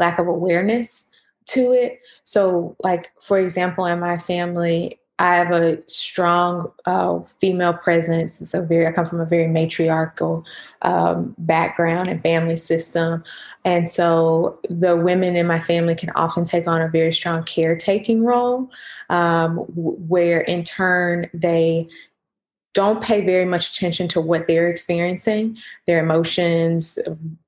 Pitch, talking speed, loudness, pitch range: 170 Hz, 140 wpm, -19 LUFS, 165-180 Hz